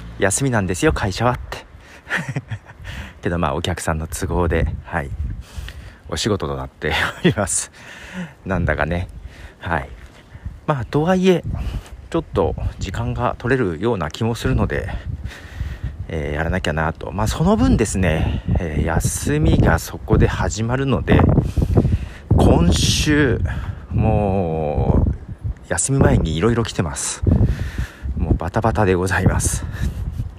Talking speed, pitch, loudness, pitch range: 225 characters per minute, 95 Hz, -20 LUFS, 80-110 Hz